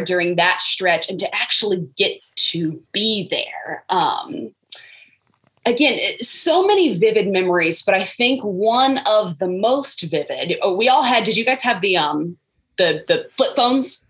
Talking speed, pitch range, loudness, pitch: 160 wpm, 180-260 Hz, -16 LUFS, 215 Hz